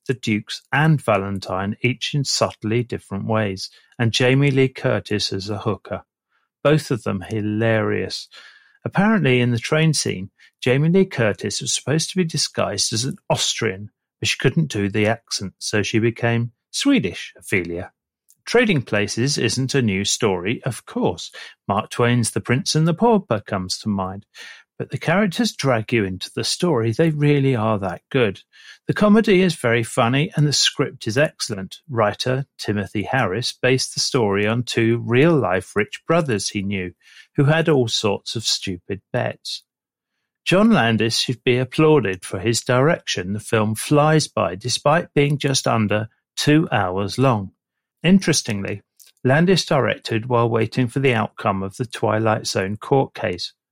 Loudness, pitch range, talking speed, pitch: -20 LUFS, 105-145 Hz, 160 wpm, 120 Hz